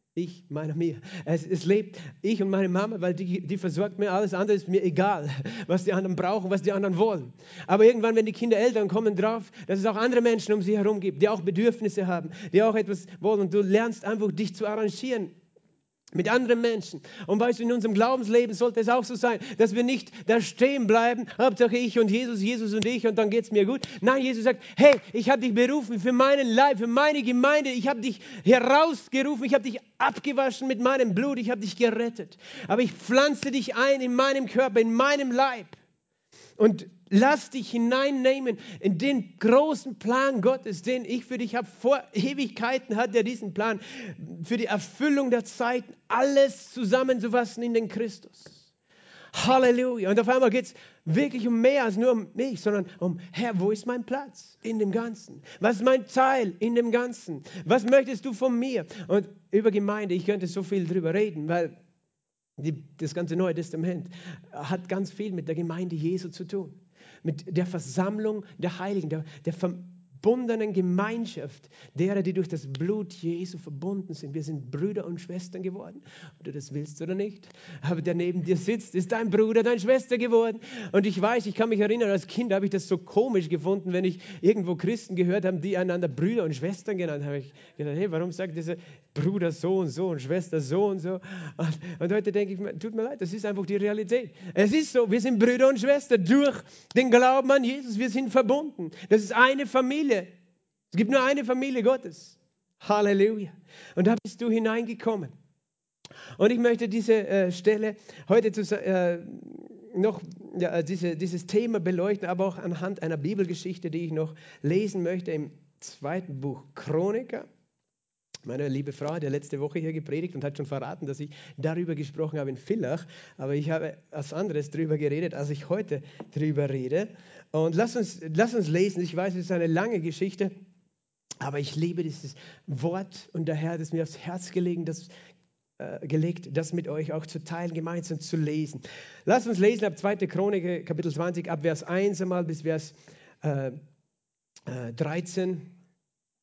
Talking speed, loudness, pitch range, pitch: 185 wpm, -26 LUFS, 170-230 Hz, 195 Hz